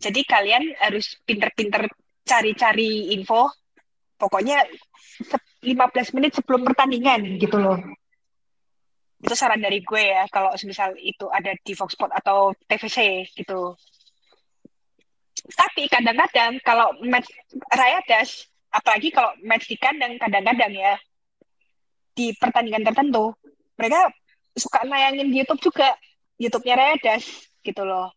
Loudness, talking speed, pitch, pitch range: -20 LUFS, 115 wpm, 230 Hz, 200-270 Hz